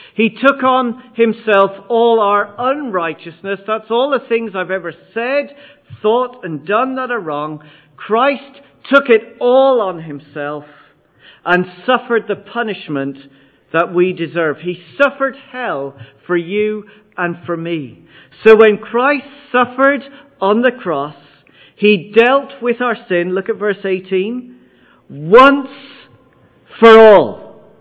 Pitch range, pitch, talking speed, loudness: 175-250 Hz, 215 Hz, 130 wpm, -14 LUFS